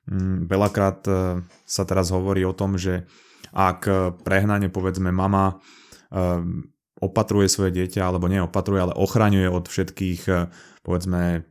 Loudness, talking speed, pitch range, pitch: -23 LUFS, 110 wpm, 90-95 Hz, 95 Hz